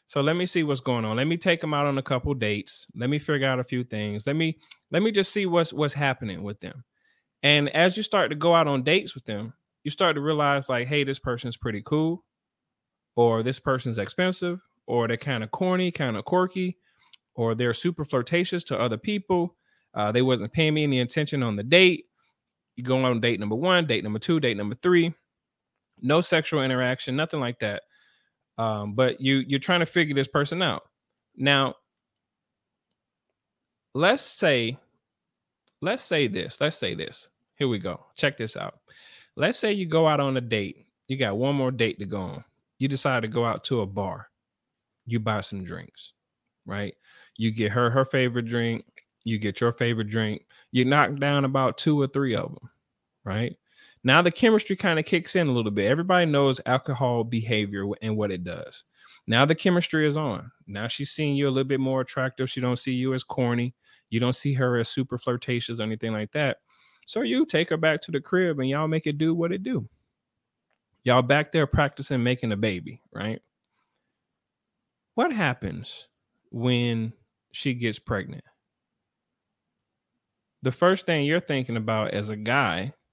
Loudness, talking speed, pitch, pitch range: -25 LUFS, 190 wpm, 135 Hz, 120-160 Hz